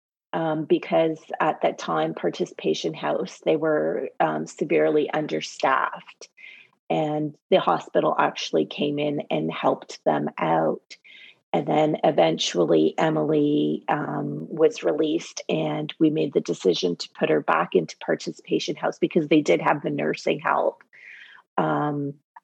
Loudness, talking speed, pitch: -24 LUFS, 130 wpm, 150 Hz